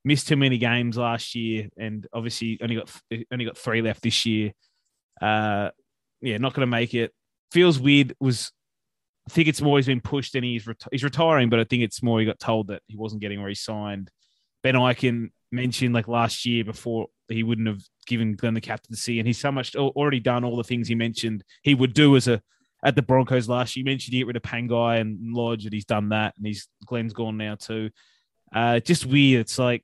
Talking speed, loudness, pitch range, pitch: 225 wpm, -24 LUFS, 110-130 Hz, 120 Hz